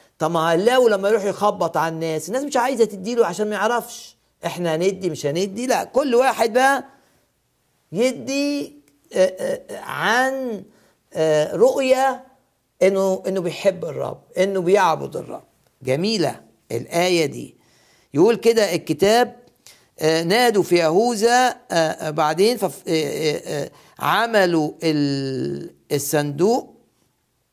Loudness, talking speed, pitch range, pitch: -20 LUFS, 95 wpm, 160-240 Hz, 195 Hz